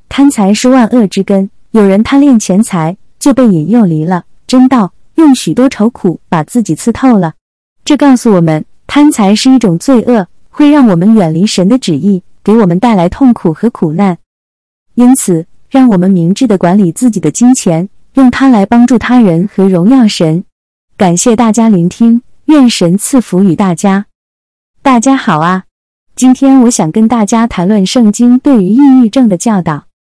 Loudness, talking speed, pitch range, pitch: -8 LUFS, 250 characters per minute, 180-250 Hz, 215 Hz